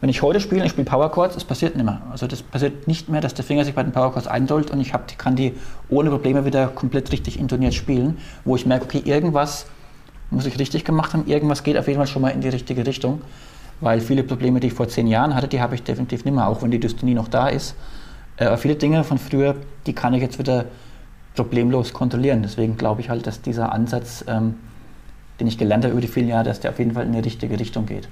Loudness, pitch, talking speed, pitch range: -21 LUFS, 130 Hz, 255 wpm, 120-140 Hz